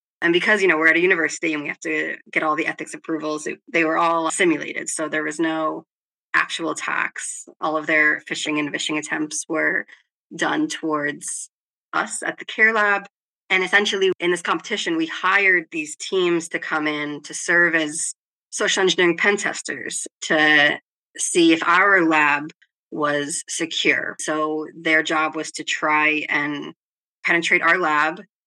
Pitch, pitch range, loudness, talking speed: 160 Hz, 155-195 Hz, -20 LUFS, 165 wpm